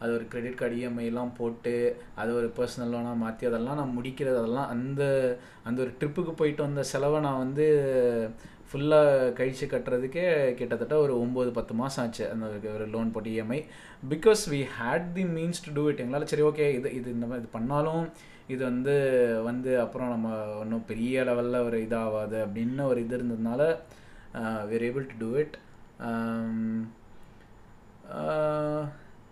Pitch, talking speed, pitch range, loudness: 125 Hz, 150 wpm, 115-140 Hz, -29 LUFS